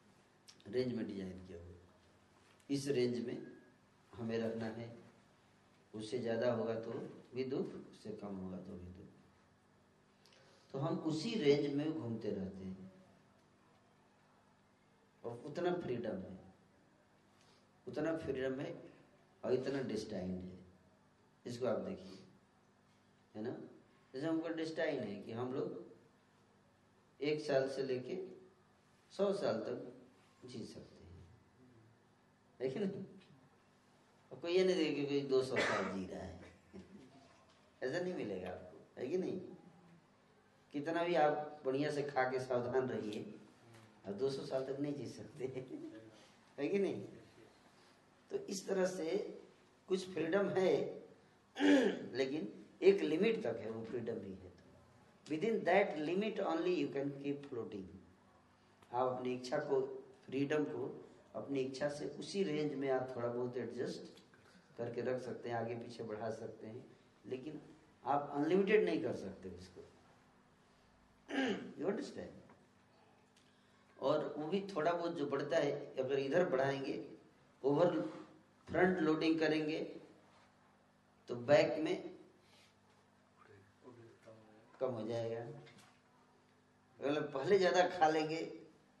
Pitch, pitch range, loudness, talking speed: 130 Hz, 115-155 Hz, -39 LUFS, 125 wpm